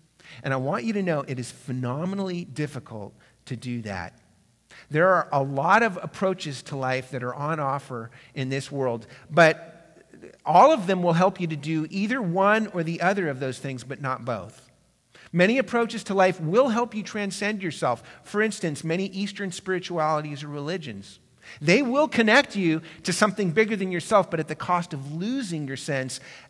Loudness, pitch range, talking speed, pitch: -25 LUFS, 135-195 Hz, 185 wpm, 160 Hz